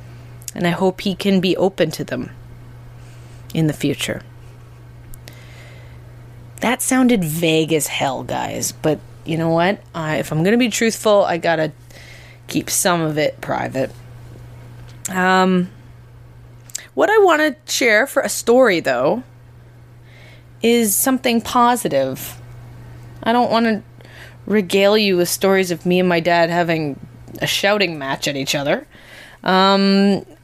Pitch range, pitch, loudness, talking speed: 120-190 Hz, 150 Hz, -17 LUFS, 135 wpm